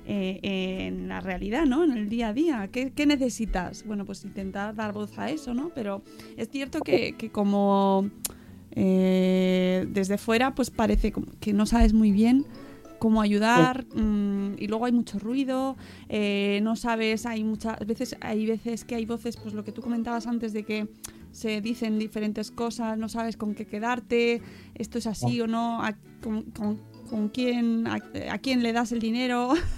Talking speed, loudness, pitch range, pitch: 185 wpm, -27 LUFS, 210-235 Hz, 220 Hz